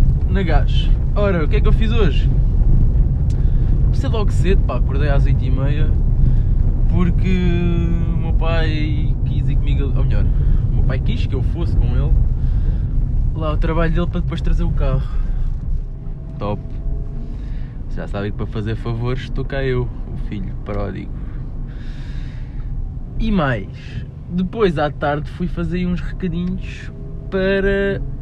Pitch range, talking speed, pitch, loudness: 120-155 Hz, 140 wpm, 130 Hz, -20 LUFS